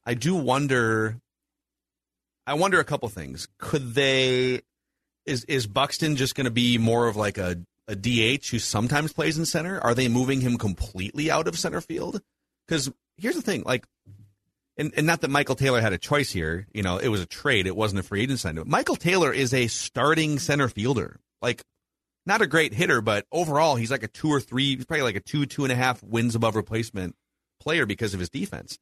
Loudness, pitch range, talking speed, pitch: -25 LUFS, 110-140 Hz, 210 wpm, 125 Hz